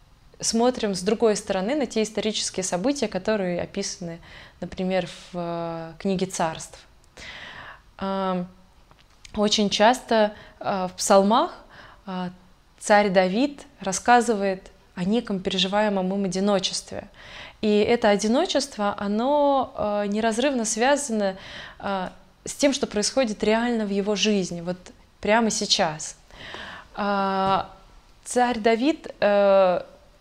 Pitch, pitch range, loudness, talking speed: 205 Hz, 190-225 Hz, -23 LUFS, 90 wpm